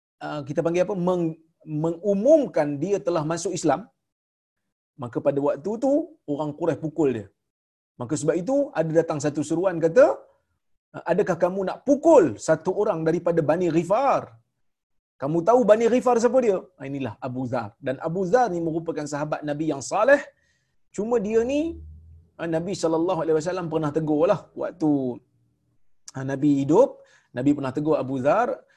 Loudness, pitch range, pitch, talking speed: -23 LUFS, 145-190 Hz, 160 Hz, 145 wpm